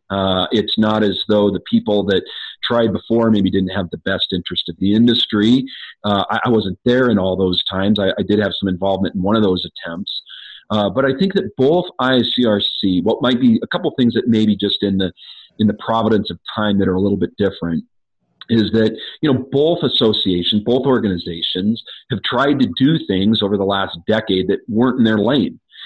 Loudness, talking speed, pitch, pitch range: -17 LUFS, 215 wpm, 105 Hz, 95-120 Hz